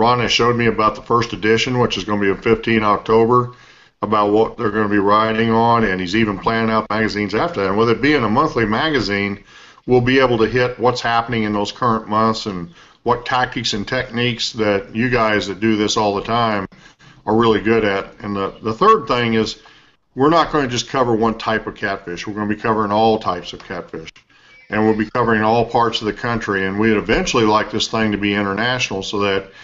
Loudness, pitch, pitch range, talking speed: -17 LUFS, 110 Hz, 105-120 Hz, 230 wpm